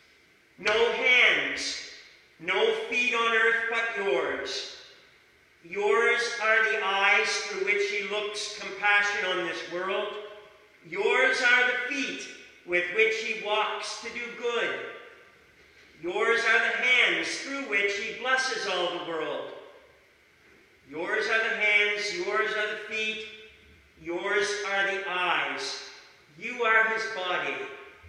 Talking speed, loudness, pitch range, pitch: 125 wpm, -26 LUFS, 205-260 Hz, 220 Hz